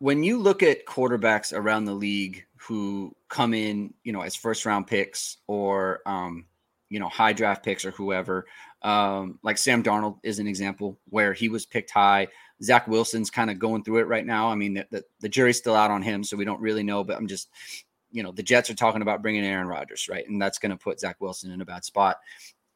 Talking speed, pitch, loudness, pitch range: 225 wpm, 105 Hz, -25 LUFS, 100-110 Hz